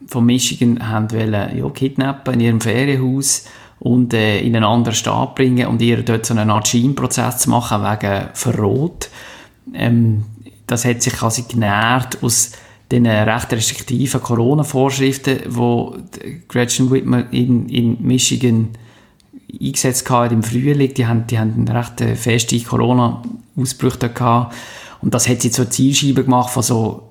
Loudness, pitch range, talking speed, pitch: -16 LUFS, 115-130 Hz, 140 wpm, 120 Hz